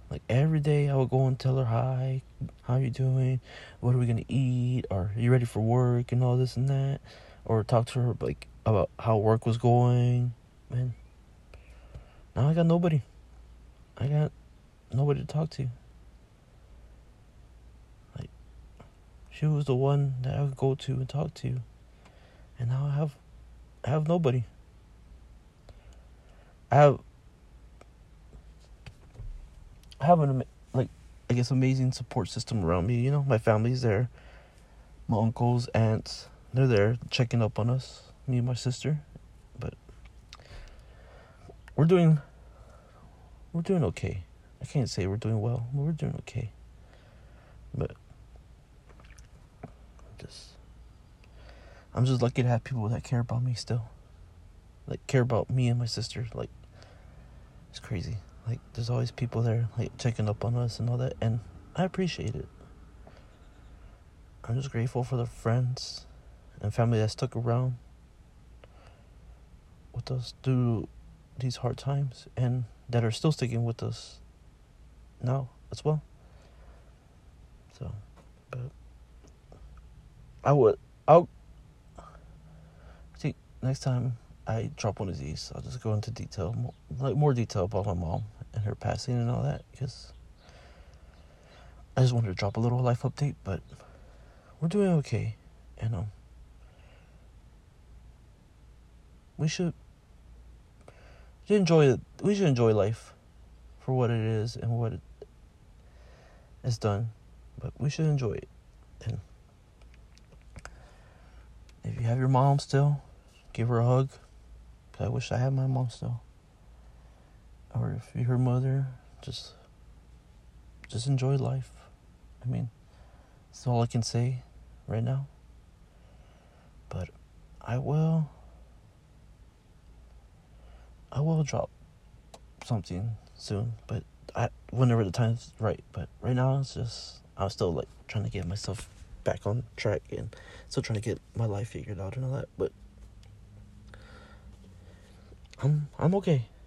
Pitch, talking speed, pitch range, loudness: 115 Hz, 140 wpm, 85-130 Hz, -29 LUFS